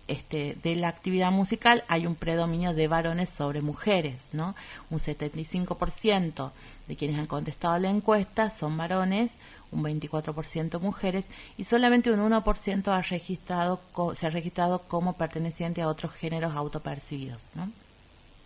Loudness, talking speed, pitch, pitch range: -28 LUFS, 140 wpm, 170 Hz, 155-190 Hz